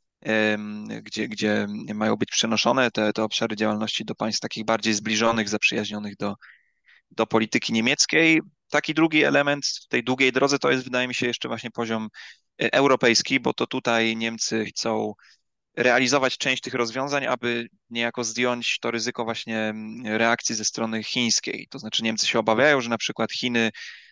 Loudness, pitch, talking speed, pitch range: -23 LUFS, 115 Hz, 155 wpm, 110-125 Hz